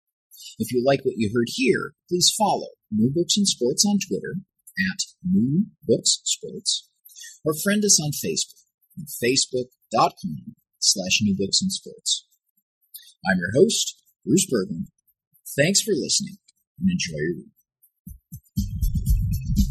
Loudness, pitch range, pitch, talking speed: -22 LUFS, 145-200 Hz, 190 Hz, 130 wpm